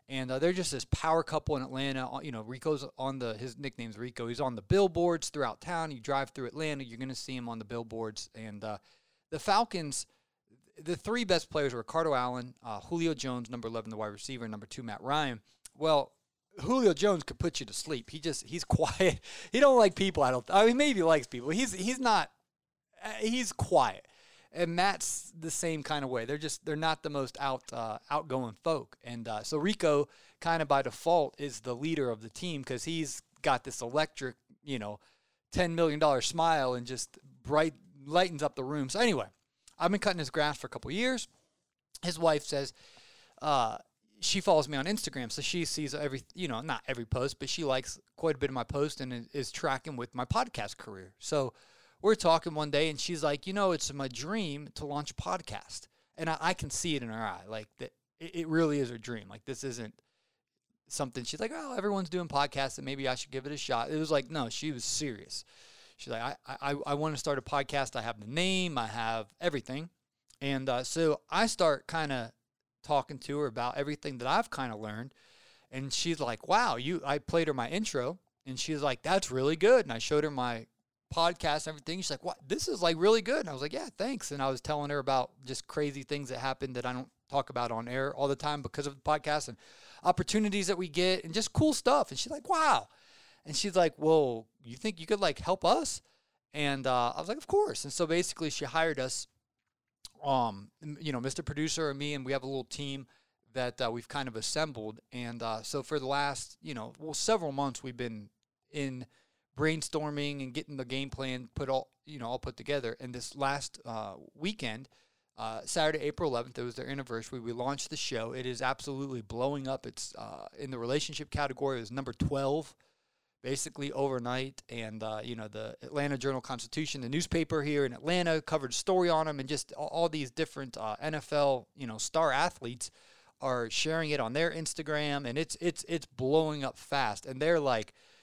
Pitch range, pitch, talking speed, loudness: 125-160 Hz, 140 Hz, 220 wpm, -33 LUFS